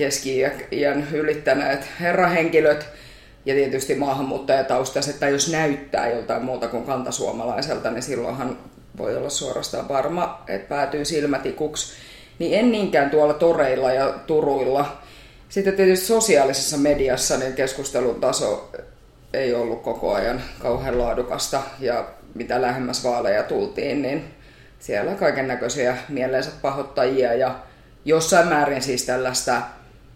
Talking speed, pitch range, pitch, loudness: 115 wpm, 130-155 Hz, 140 Hz, -22 LUFS